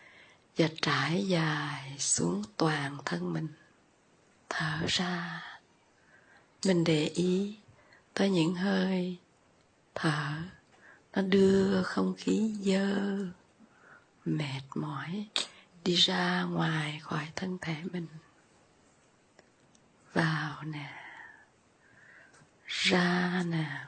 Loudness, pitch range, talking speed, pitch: -31 LUFS, 155-190 Hz, 85 wpm, 175 Hz